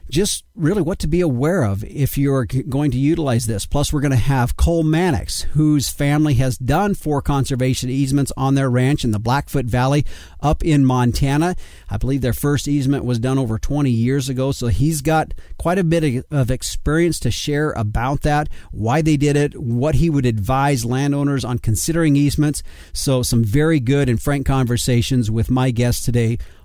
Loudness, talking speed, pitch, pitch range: -18 LUFS, 185 wpm, 135 Hz, 120-150 Hz